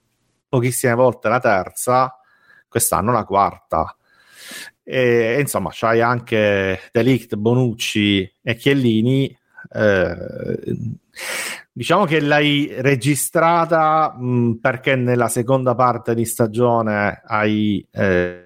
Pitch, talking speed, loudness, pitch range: 120 Hz, 100 wpm, -18 LUFS, 115-130 Hz